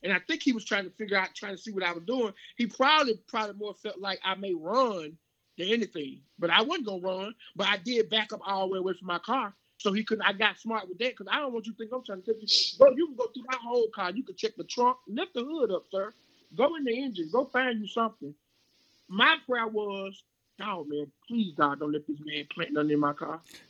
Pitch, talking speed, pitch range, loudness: 210 Hz, 270 wpm, 180-240 Hz, -29 LUFS